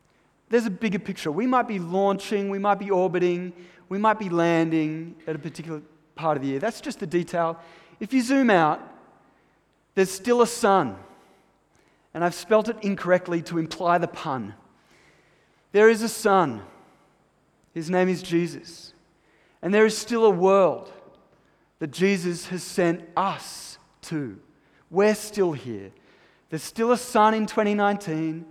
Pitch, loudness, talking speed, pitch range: 185 Hz, -24 LUFS, 155 wpm, 165-210 Hz